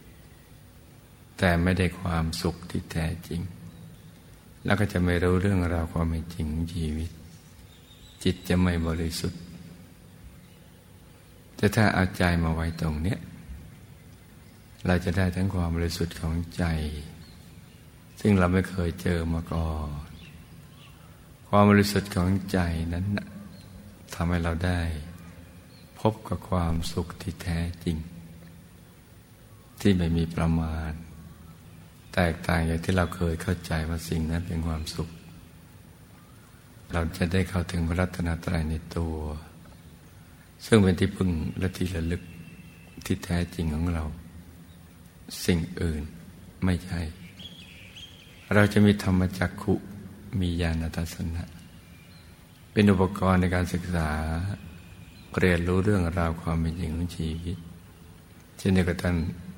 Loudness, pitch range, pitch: -27 LUFS, 85-90 Hz, 85 Hz